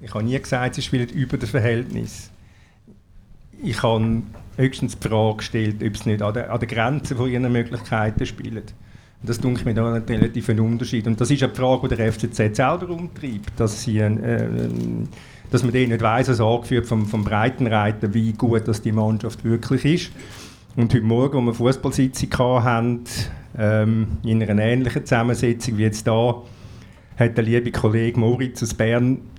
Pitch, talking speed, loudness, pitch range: 115 Hz, 170 wpm, -21 LUFS, 110-125 Hz